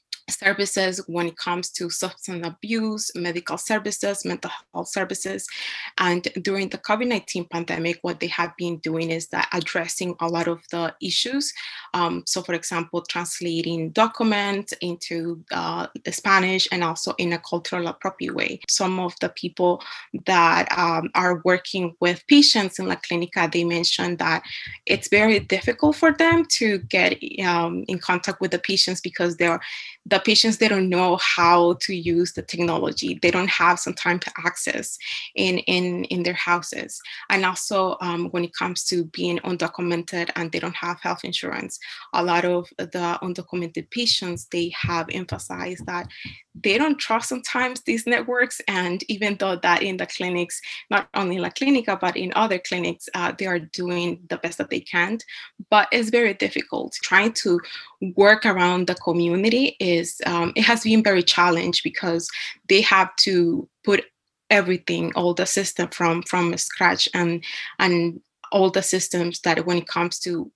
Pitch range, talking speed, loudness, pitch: 170-200 Hz, 165 wpm, -22 LUFS, 180 Hz